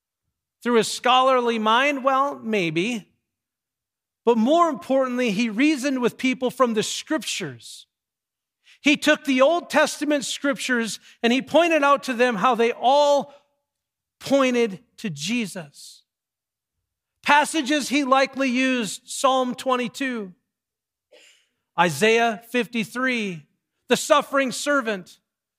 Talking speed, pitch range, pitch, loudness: 105 wpm, 225-280 Hz, 250 Hz, -21 LUFS